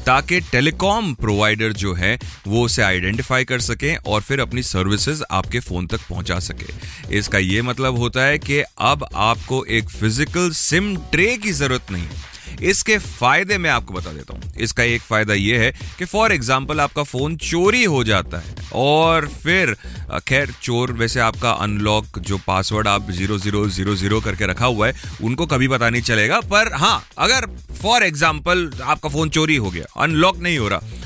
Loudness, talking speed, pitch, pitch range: -18 LUFS, 180 wpm, 120 Hz, 100-150 Hz